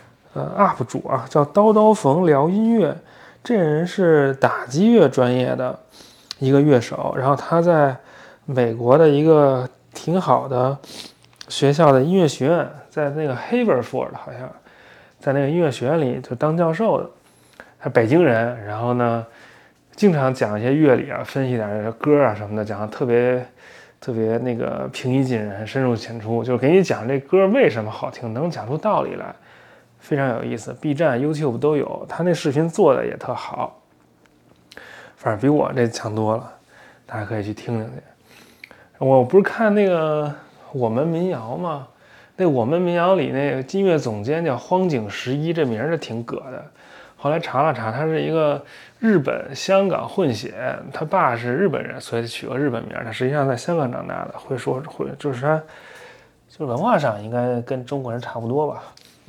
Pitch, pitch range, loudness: 140 Hz, 120-160 Hz, -20 LUFS